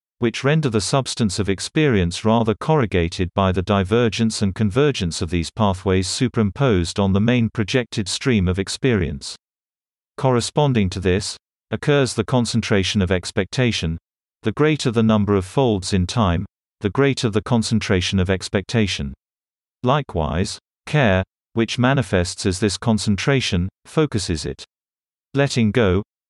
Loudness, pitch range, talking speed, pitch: -20 LUFS, 95-120 Hz, 130 wpm, 105 Hz